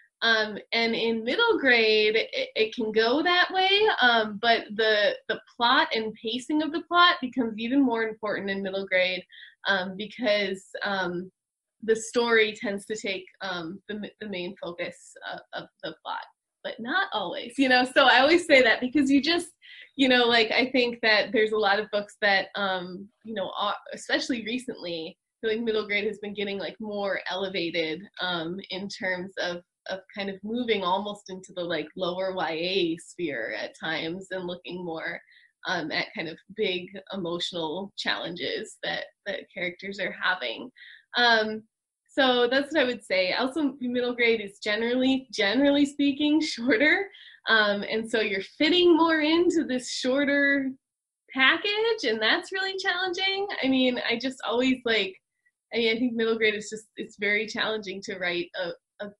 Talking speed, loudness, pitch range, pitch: 170 wpm, -25 LUFS, 195-280 Hz, 225 Hz